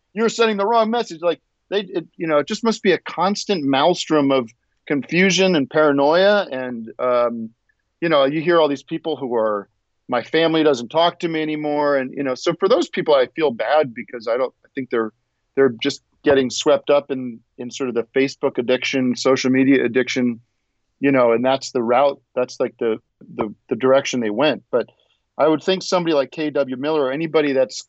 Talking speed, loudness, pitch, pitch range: 205 wpm, -19 LUFS, 140 Hz, 125-165 Hz